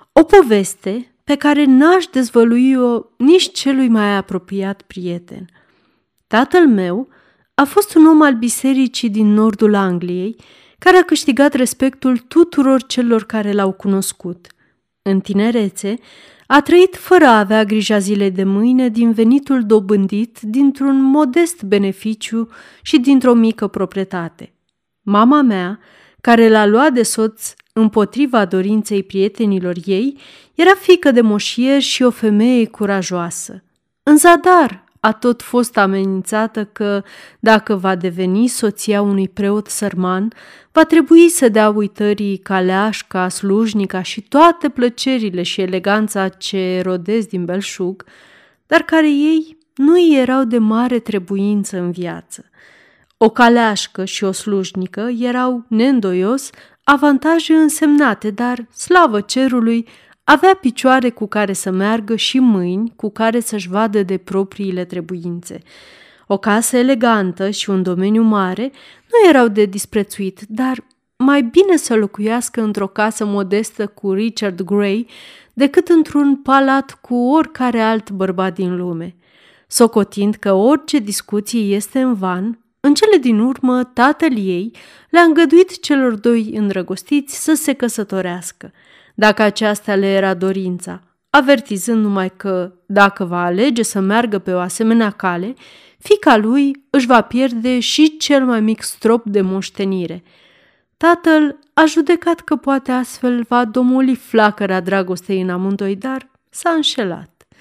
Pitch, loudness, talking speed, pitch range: 220 Hz, -14 LUFS, 130 wpm, 195-265 Hz